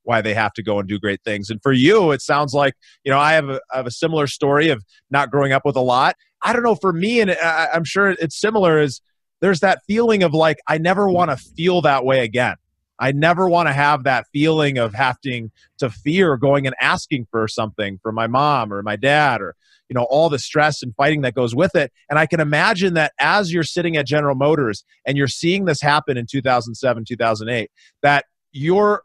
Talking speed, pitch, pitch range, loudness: 230 wpm, 145 Hz, 125-165 Hz, -18 LUFS